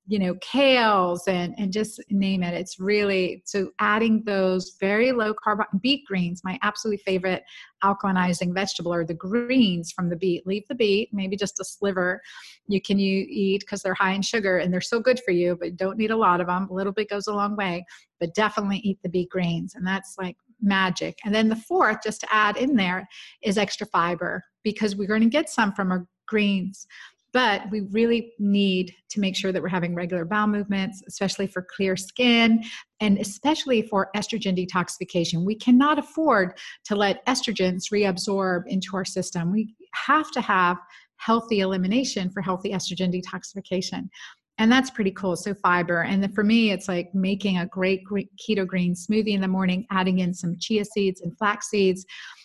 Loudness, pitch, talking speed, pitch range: -24 LUFS, 195 Hz, 190 wpm, 185-215 Hz